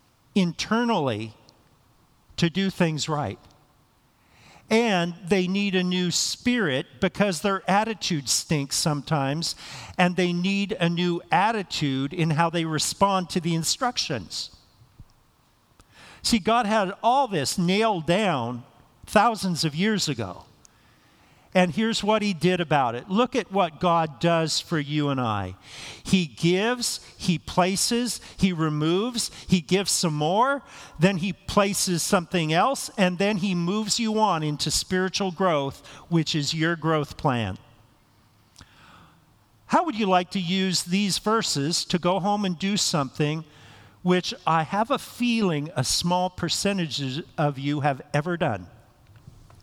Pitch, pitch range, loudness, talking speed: 175 Hz, 150-200 Hz, -24 LUFS, 135 wpm